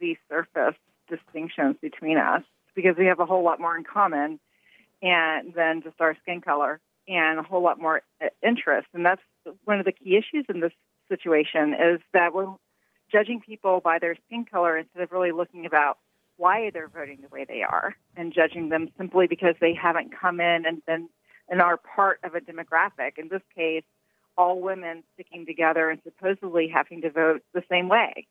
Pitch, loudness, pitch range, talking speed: 170 Hz, -24 LUFS, 160-185 Hz, 190 wpm